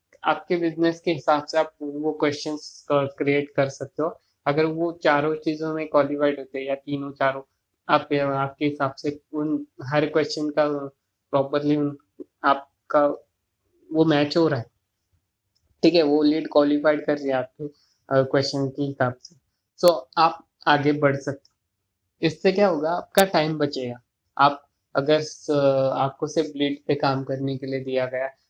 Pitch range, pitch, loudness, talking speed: 135-155 Hz, 145 Hz, -23 LUFS, 160 wpm